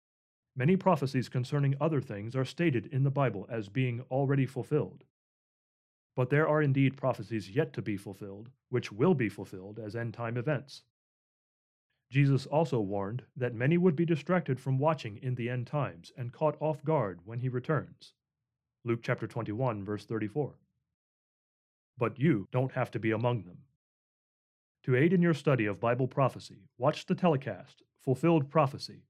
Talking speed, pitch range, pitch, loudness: 160 wpm, 115-150 Hz, 130 Hz, -31 LUFS